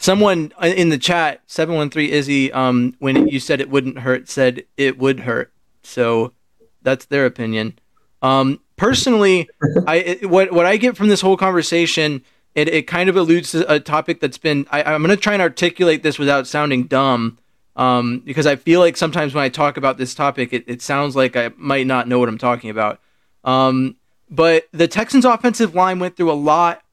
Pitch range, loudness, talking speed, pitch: 130-170 Hz, -17 LUFS, 195 wpm, 145 Hz